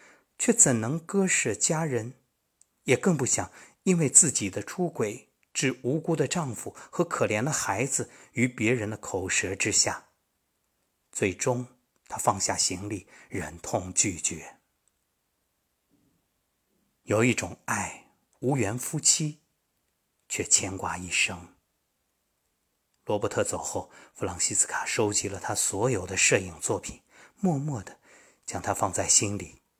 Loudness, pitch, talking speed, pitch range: -26 LUFS, 120 Hz, 185 characters per minute, 100-150 Hz